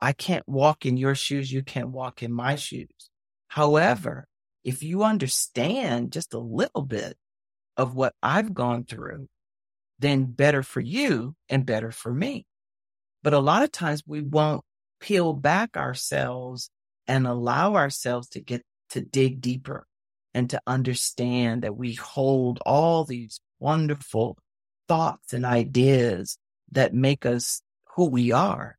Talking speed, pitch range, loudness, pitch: 145 wpm, 120-145 Hz, -25 LUFS, 130 Hz